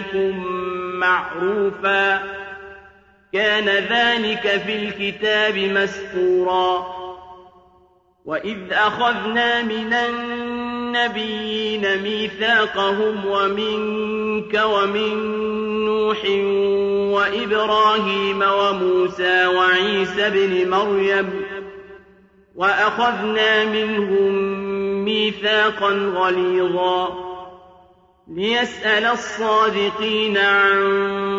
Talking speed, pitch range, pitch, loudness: 50 wpm, 195-215 Hz, 200 Hz, -19 LUFS